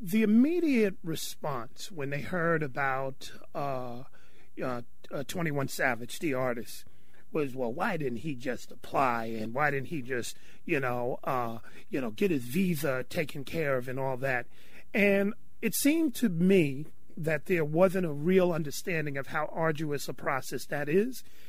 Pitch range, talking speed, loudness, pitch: 135-185 Hz, 165 wpm, -30 LUFS, 155 Hz